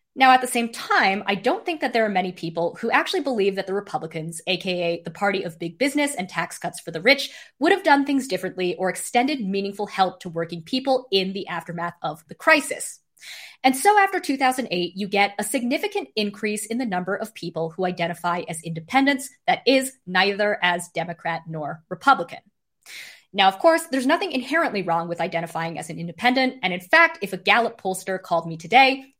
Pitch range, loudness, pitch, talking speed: 175-265 Hz, -22 LUFS, 200 Hz, 195 wpm